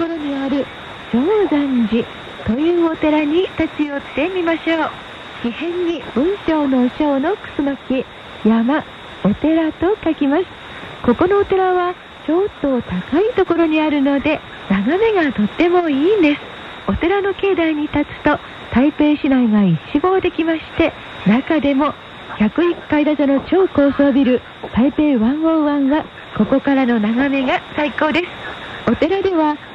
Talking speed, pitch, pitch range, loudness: 265 characters per minute, 300 Hz, 275-335 Hz, -17 LUFS